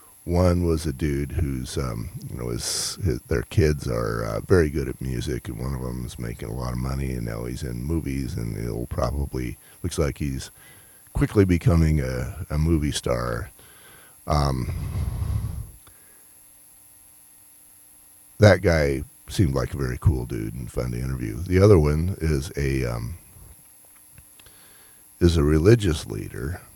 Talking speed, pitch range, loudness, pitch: 155 wpm, 60-85 Hz, -24 LUFS, 70 Hz